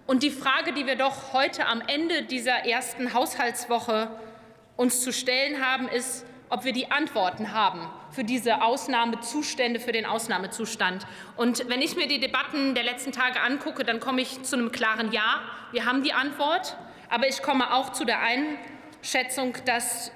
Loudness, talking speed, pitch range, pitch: -26 LUFS, 170 wpm, 235-270 Hz, 250 Hz